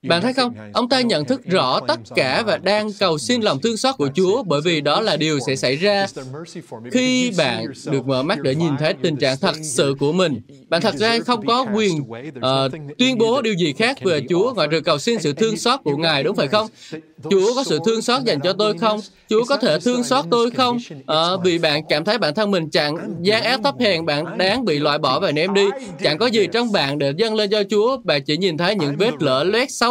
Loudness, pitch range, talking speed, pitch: -19 LUFS, 155-230 Hz, 245 wpm, 195 Hz